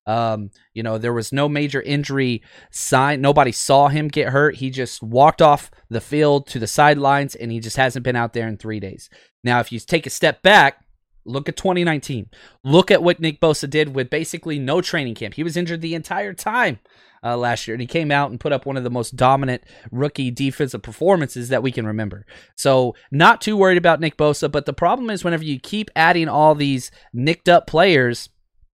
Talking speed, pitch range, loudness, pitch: 215 wpm, 120-155 Hz, -18 LUFS, 140 Hz